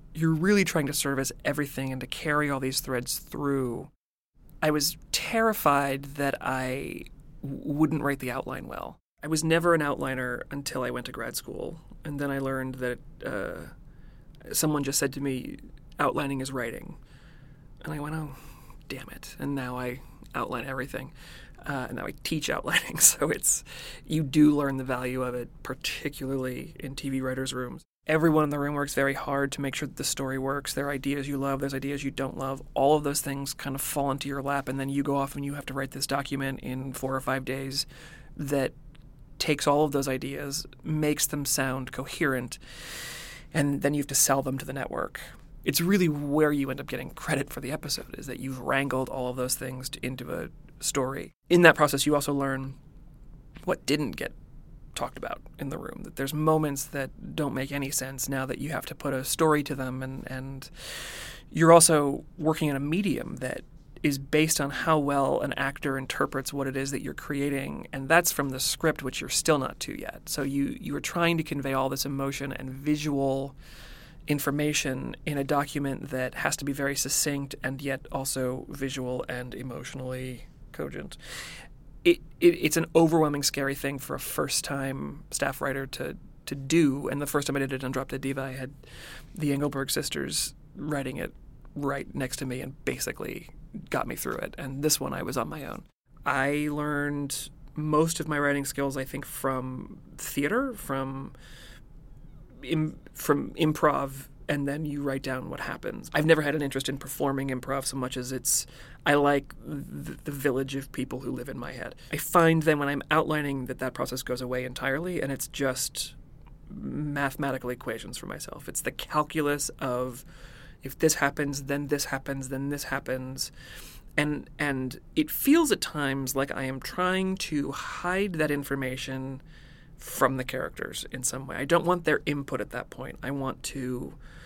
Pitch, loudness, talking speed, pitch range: 140 Hz, -28 LUFS, 190 wpm, 135-150 Hz